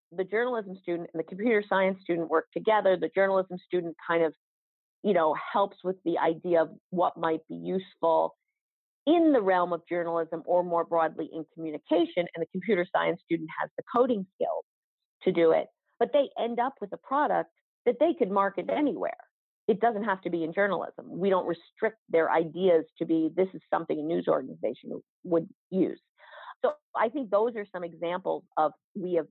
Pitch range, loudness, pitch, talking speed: 165-205 Hz, -28 LUFS, 180 Hz, 190 wpm